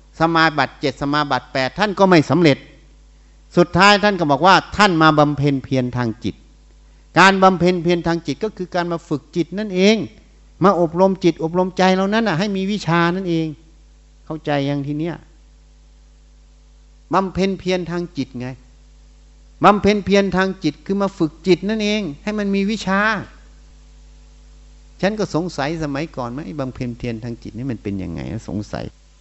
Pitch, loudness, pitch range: 160 Hz, -18 LUFS, 125-185 Hz